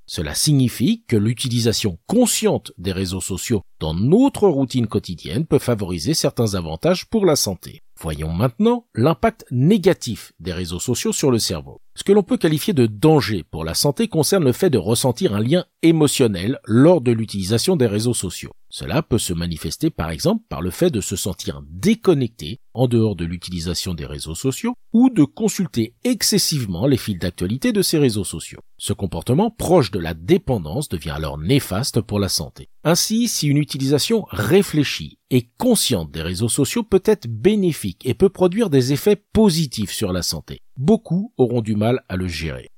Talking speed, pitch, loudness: 175 wpm, 125 Hz, -19 LUFS